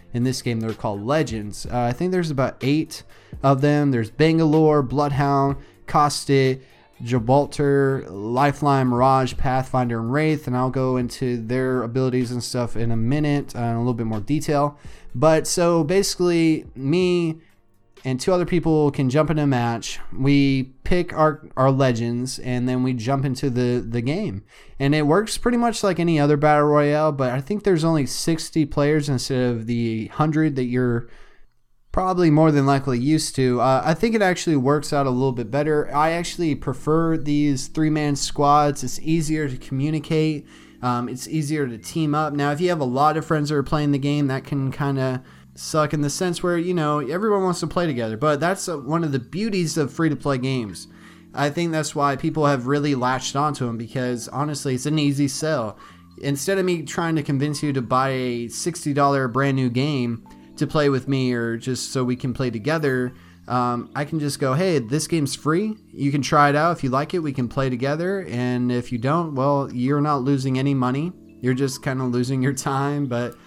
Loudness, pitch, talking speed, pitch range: -21 LUFS, 140 Hz, 200 wpm, 125-155 Hz